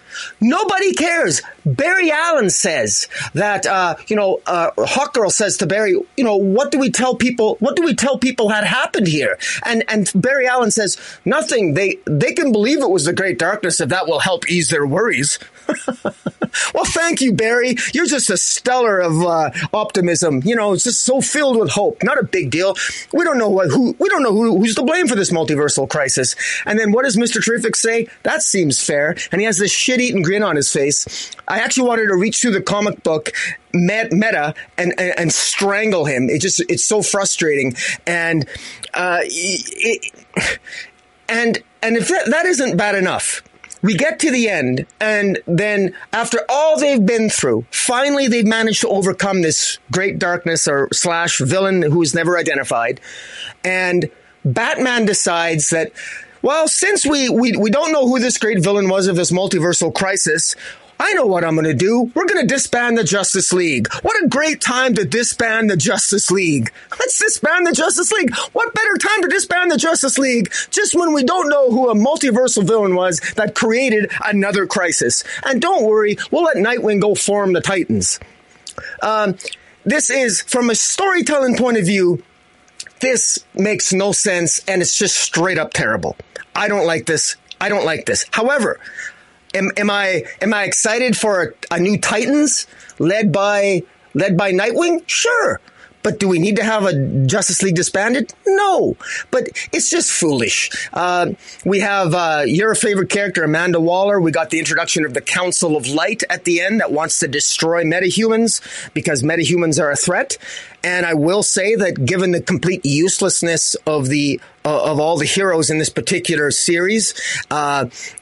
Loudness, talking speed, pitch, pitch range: -16 LUFS, 180 wpm, 205 Hz, 175-250 Hz